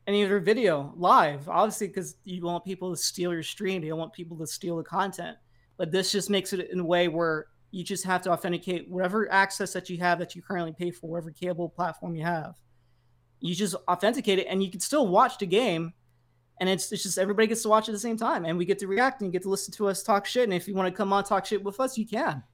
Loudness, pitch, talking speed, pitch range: -27 LUFS, 185 Hz, 270 wpm, 170-200 Hz